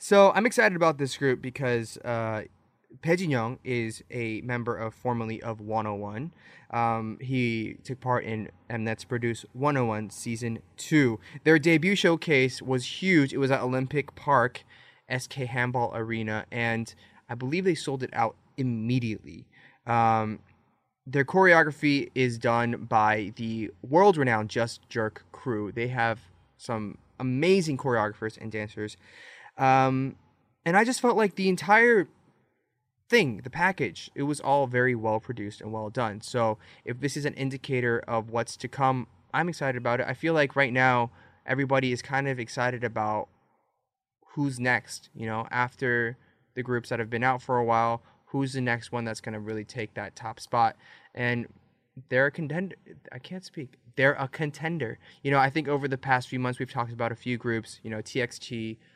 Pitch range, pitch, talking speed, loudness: 115-135 Hz, 125 Hz, 165 wpm, -27 LUFS